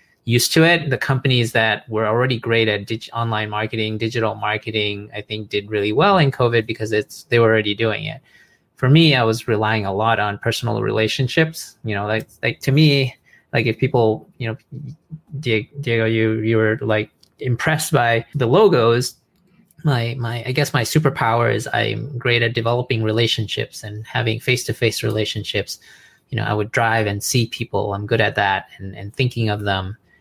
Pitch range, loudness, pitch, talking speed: 110-130 Hz, -19 LUFS, 115 Hz, 185 wpm